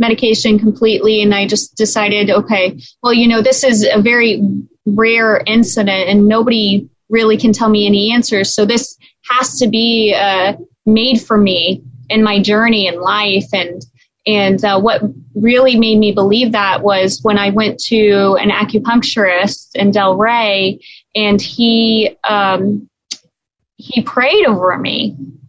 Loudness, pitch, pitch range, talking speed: -12 LUFS, 210 Hz, 200-225 Hz, 150 wpm